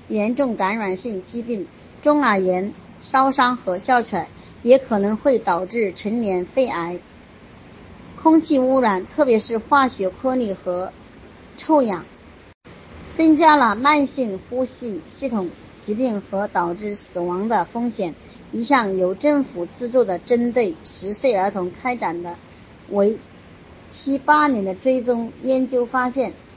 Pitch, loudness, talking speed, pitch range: 235 Hz, -20 LUFS, 195 characters per minute, 195-260 Hz